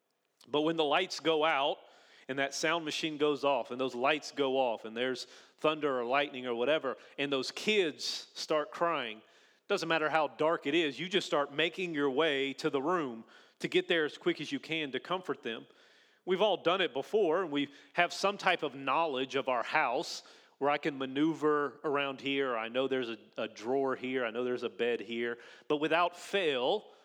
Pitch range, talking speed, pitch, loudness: 130-165 Hz, 205 wpm, 145 Hz, -32 LUFS